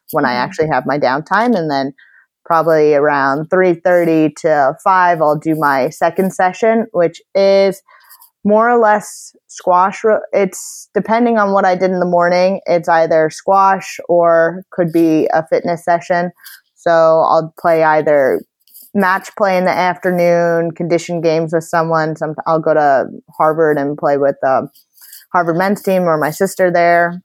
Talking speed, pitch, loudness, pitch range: 155 wpm, 175 Hz, -14 LUFS, 160-190 Hz